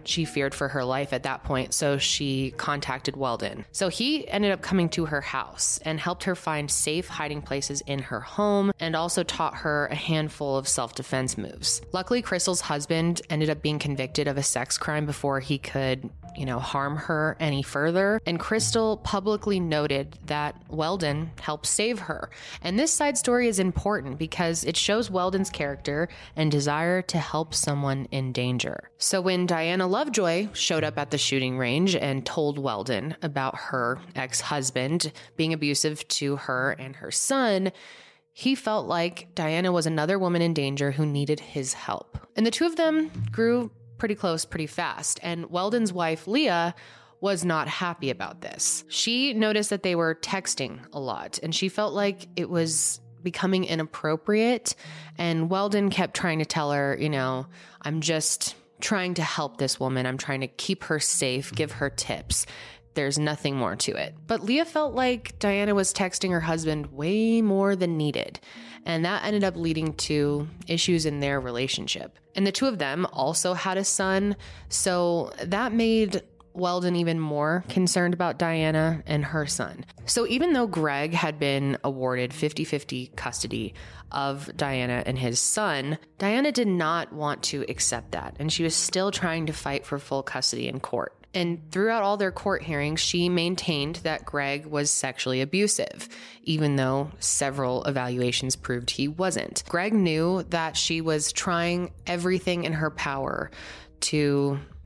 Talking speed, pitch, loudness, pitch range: 170 wpm, 160 Hz, -26 LUFS, 140-185 Hz